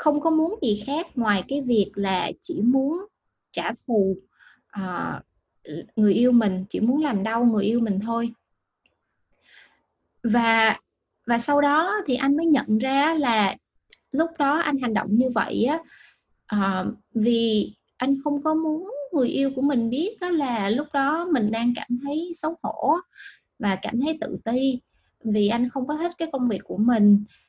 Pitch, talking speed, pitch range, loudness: 245 Hz, 170 wpm, 220-295 Hz, -24 LUFS